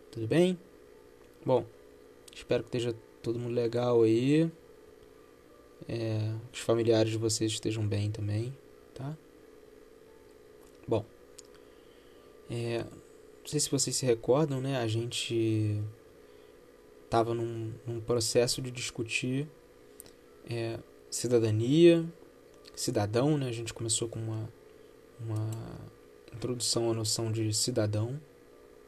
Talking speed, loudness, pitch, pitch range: 105 wpm, -30 LUFS, 115 Hz, 110-125 Hz